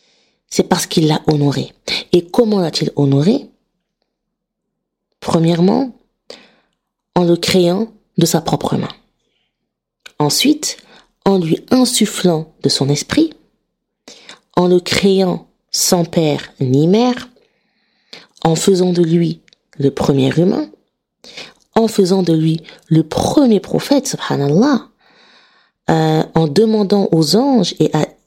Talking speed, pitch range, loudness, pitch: 115 wpm, 160-225 Hz, -15 LUFS, 180 Hz